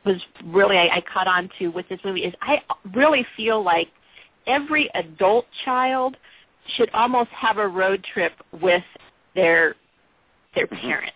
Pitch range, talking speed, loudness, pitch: 180-255 Hz, 150 wpm, -21 LUFS, 210 Hz